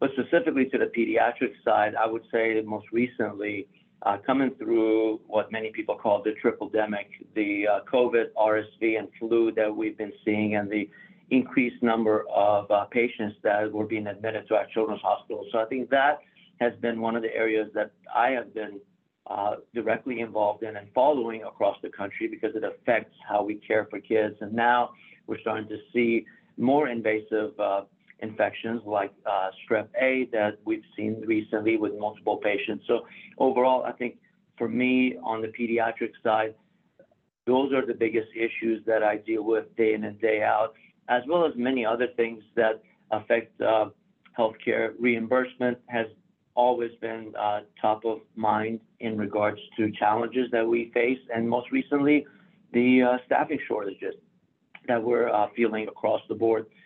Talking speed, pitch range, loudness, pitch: 170 wpm, 110-120 Hz, -27 LUFS, 115 Hz